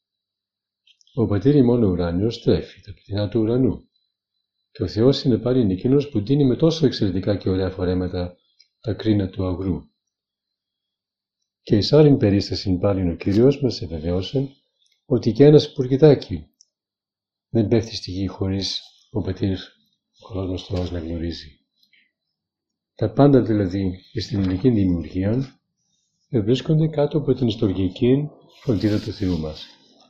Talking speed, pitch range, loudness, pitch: 130 wpm, 95-125 Hz, -21 LUFS, 100 Hz